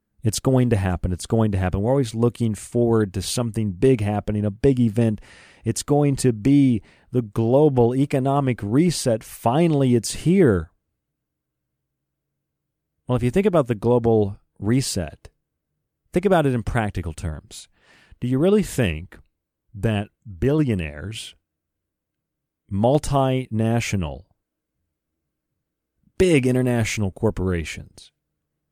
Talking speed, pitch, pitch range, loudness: 115 wpm, 115 Hz, 95-130 Hz, -21 LUFS